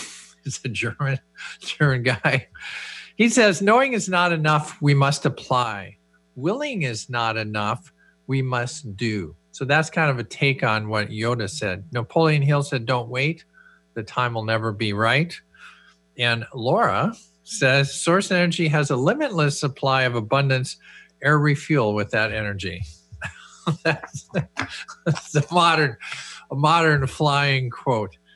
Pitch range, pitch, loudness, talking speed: 110-155 Hz, 135 Hz, -22 LUFS, 140 wpm